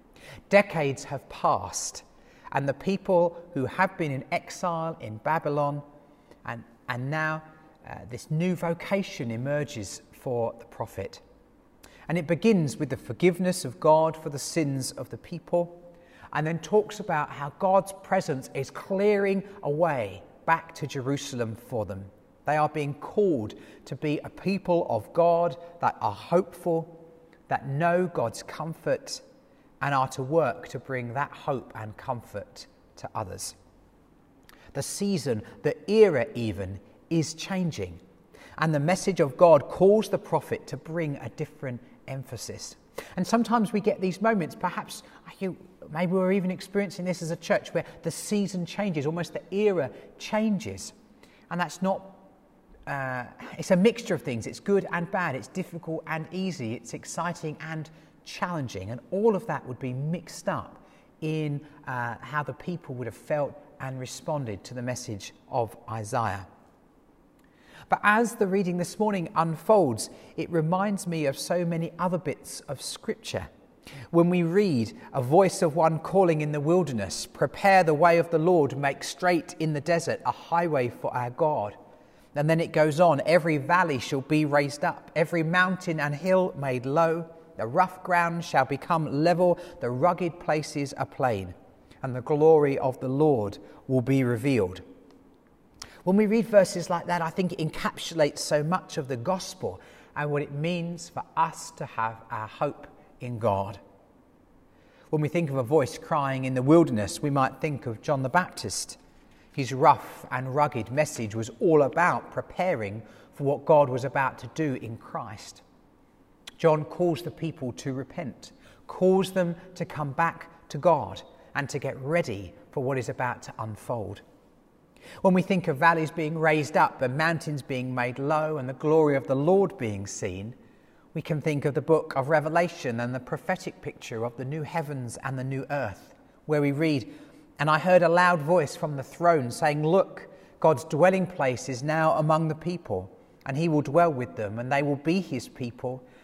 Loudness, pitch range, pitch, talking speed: -27 LUFS, 130-175 Hz, 155 Hz, 170 wpm